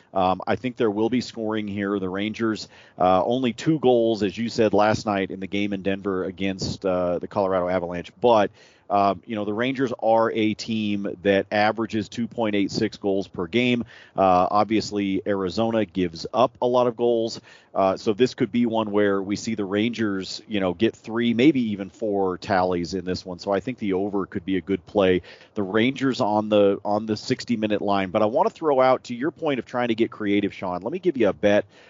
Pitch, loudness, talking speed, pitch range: 105 Hz, -23 LUFS, 215 wpm, 95-115 Hz